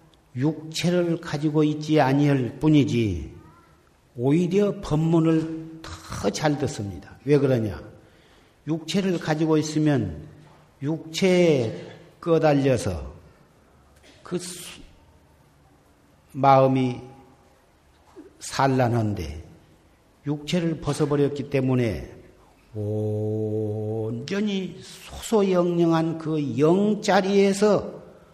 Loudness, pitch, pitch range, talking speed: -23 LUFS, 145 Hz, 110-160 Hz, 165 characters per minute